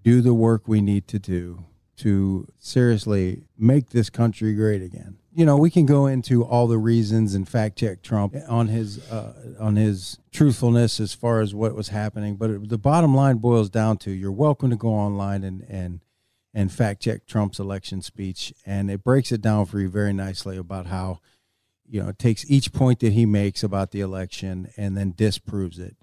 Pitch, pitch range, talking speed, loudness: 110 Hz, 100-115 Hz, 200 wpm, -22 LUFS